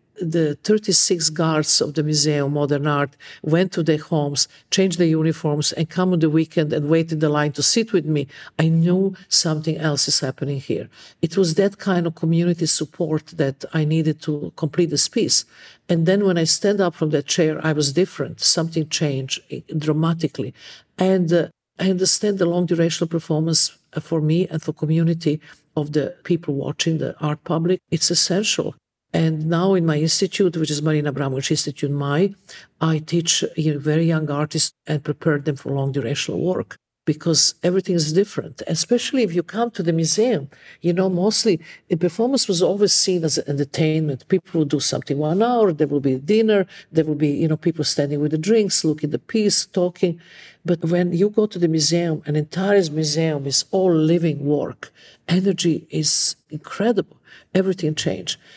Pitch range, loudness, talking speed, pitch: 150-180 Hz, -20 LUFS, 180 wpm, 160 Hz